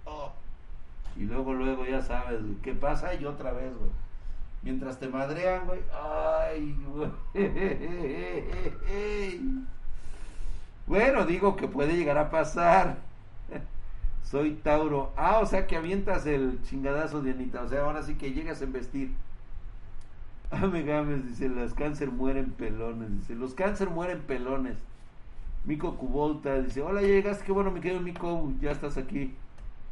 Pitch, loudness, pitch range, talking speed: 140 Hz, -31 LUFS, 130-170 Hz, 140 wpm